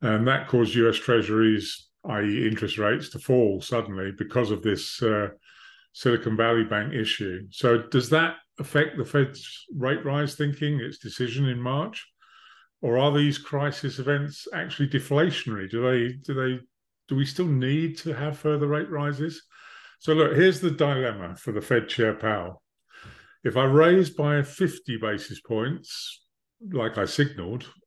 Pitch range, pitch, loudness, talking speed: 110-150 Hz, 135 Hz, -25 LUFS, 155 wpm